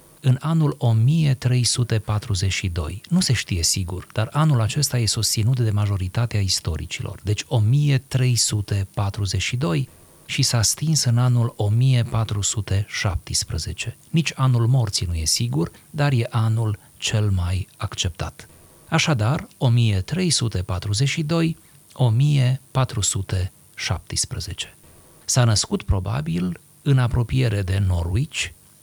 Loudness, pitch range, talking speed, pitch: -21 LUFS, 100-135 Hz, 90 wpm, 115 Hz